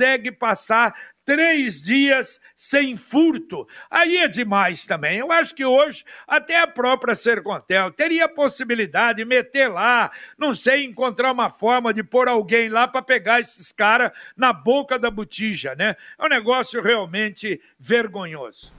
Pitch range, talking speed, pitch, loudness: 225-275 Hz, 145 wpm, 245 Hz, -19 LUFS